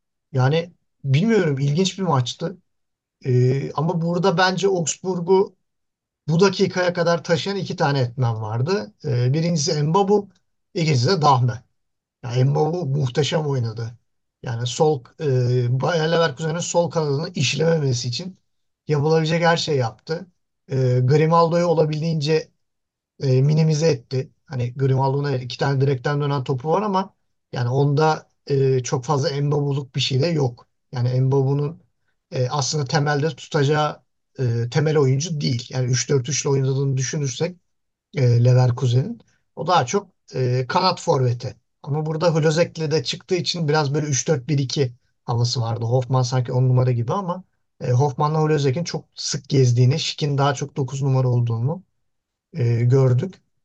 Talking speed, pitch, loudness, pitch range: 130 wpm, 145 Hz, -21 LUFS, 130-165 Hz